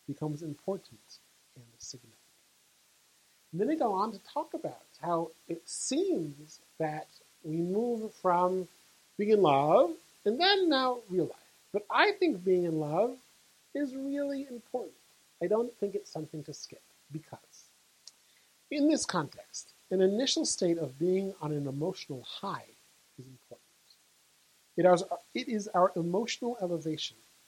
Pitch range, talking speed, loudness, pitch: 155-240 Hz, 140 wpm, -31 LUFS, 185 Hz